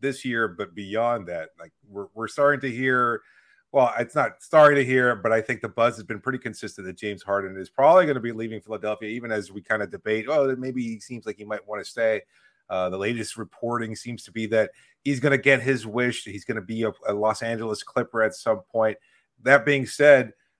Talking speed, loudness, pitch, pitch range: 235 wpm, -24 LUFS, 115 Hz, 105-130 Hz